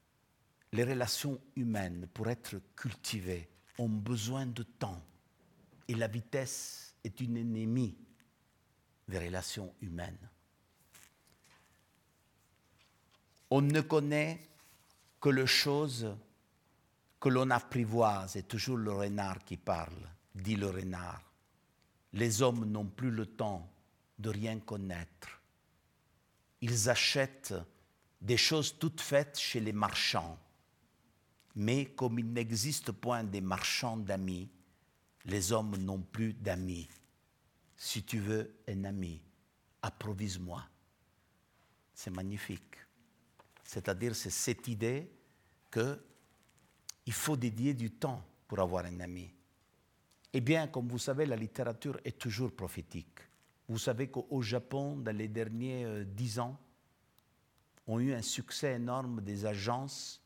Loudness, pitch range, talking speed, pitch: -36 LUFS, 100-125 Hz, 115 wpm, 115 Hz